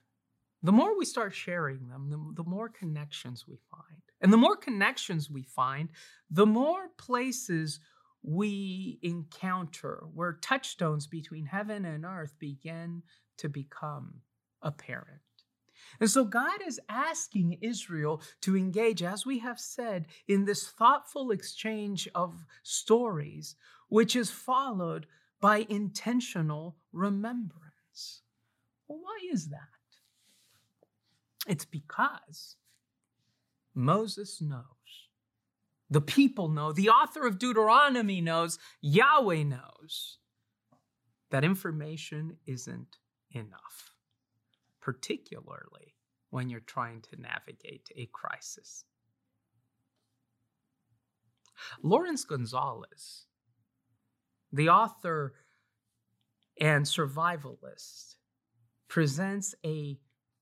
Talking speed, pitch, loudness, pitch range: 95 wpm, 160 Hz, -30 LUFS, 130-205 Hz